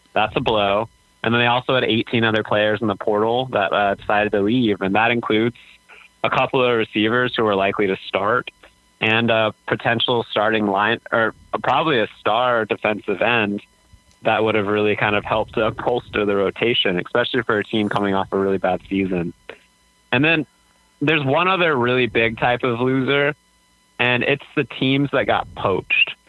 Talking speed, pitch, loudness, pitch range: 185 wpm, 110 Hz, -19 LUFS, 105-120 Hz